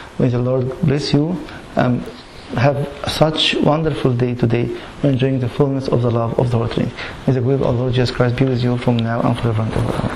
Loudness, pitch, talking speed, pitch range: -18 LUFS, 125 Hz, 225 wpm, 120-140 Hz